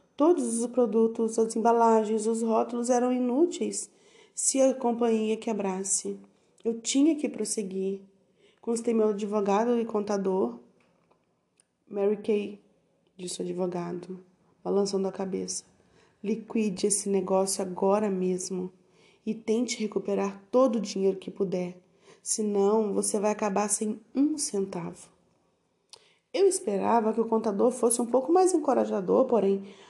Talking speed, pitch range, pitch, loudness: 120 wpm, 195-230 Hz, 215 Hz, -27 LUFS